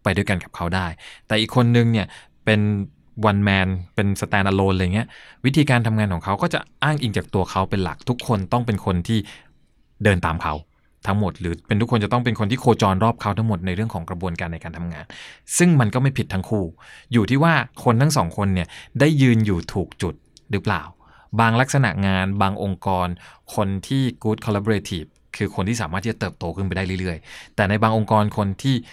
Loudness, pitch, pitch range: -21 LUFS, 105 Hz, 95-115 Hz